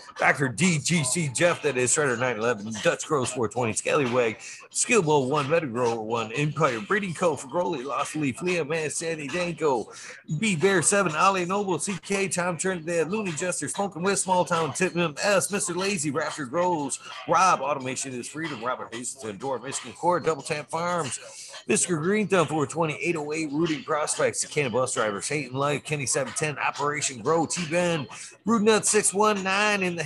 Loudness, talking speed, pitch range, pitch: -25 LUFS, 165 wpm, 150-185 Hz, 170 Hz